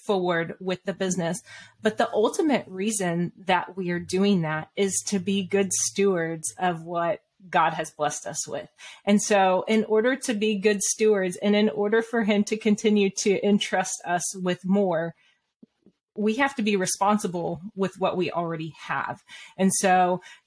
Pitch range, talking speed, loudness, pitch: 180-215 Hz, 165 wpm, -25 LUFS, 195 Hz